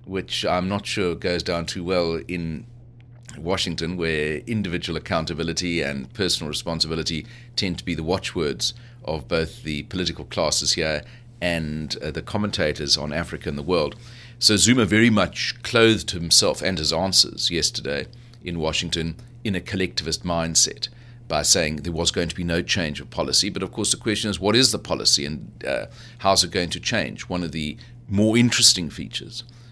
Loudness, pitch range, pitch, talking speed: -22 LUFS, 80-120 Hz, 95 Hz, 175 wpm